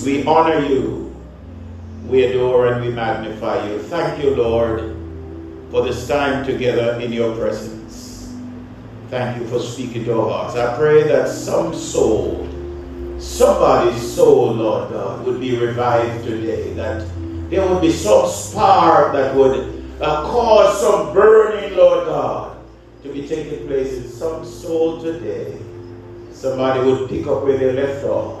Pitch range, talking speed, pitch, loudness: 110-145 Hz, 150 wpm, 120 Hz, -17 LUFS